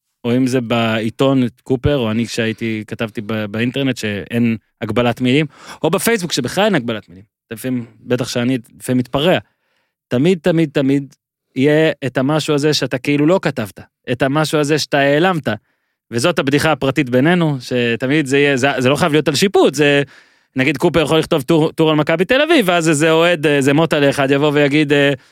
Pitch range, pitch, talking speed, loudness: 120-155 Hz, 140 Hz, 175 wpm, -16 LUFS